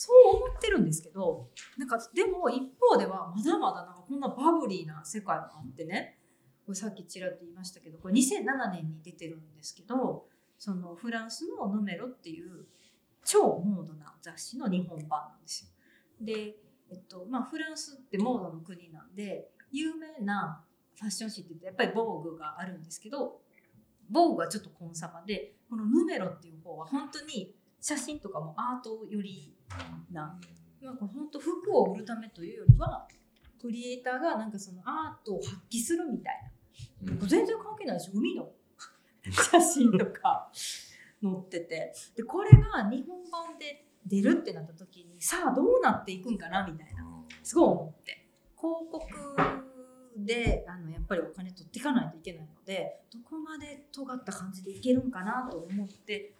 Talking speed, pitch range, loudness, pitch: 350 characters per minute, 175-270 Hz, -30 LUFS, 210 Hz